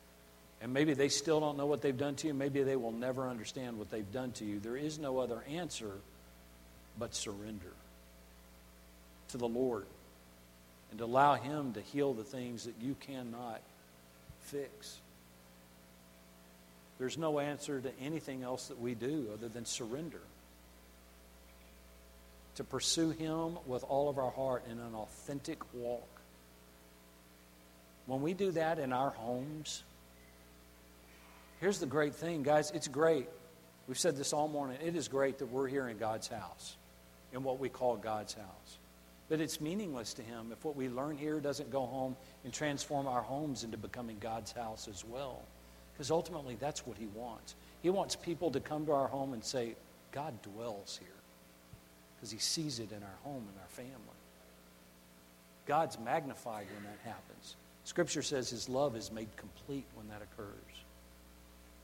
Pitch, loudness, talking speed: 115 Hz, -38 LUFS, 160 wpm